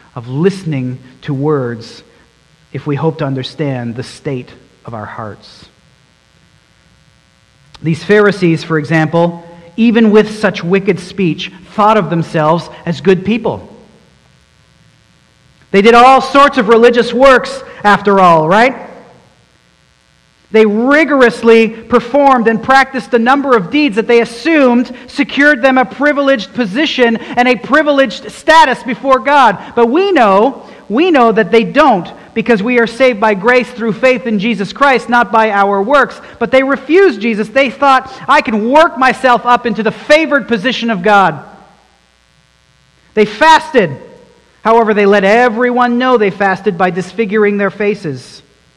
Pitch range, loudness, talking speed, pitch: 185-255 Hz, -10 LUFS, 140 wpm, 225 Hz